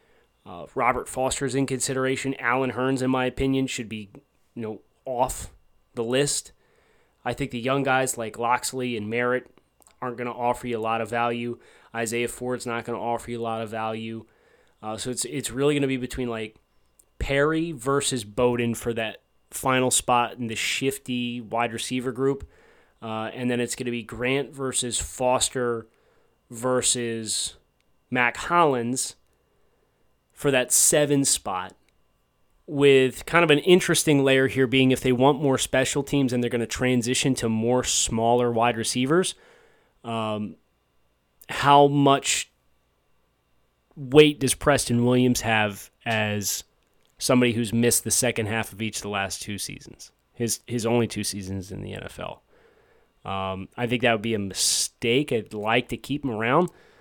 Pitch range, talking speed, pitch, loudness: 115-135 Hz, 160 wpm, 120 Hz, -24 LUFS